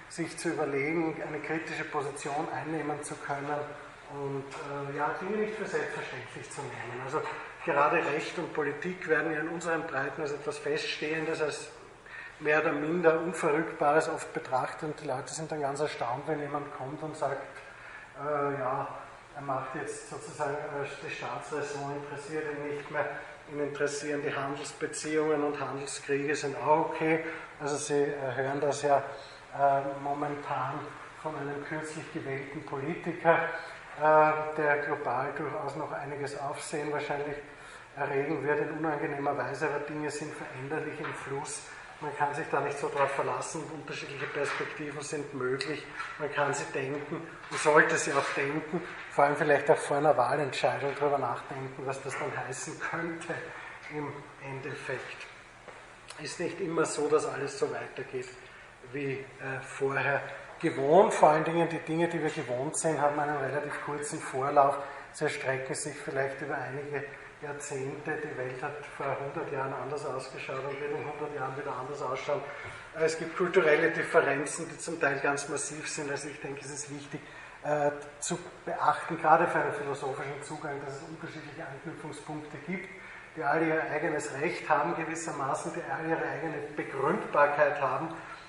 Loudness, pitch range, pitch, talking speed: -31 LUFS, 140-155 Hz, 145 Hz, 155 wpm